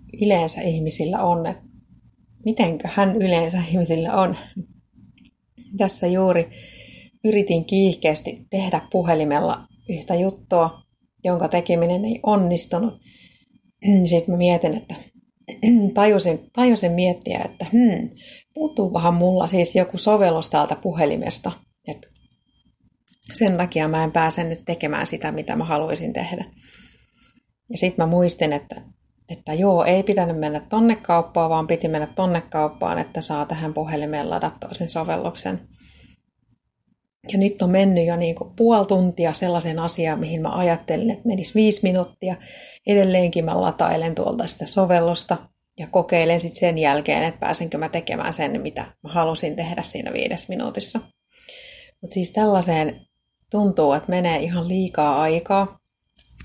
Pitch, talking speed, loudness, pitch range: 175 Hz, 130 wpm, -21 LUFS, 165-200 Hz